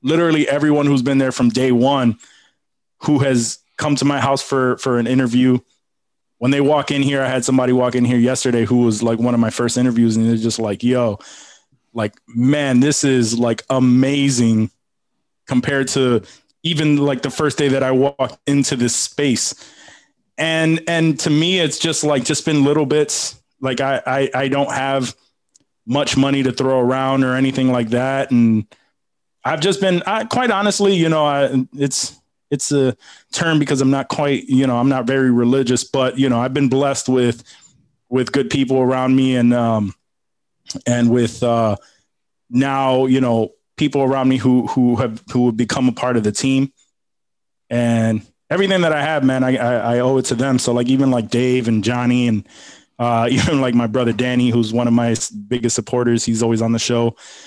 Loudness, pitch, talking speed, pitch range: -17 LUFS, 130 Hz, 190 wpm, 120-140 Hz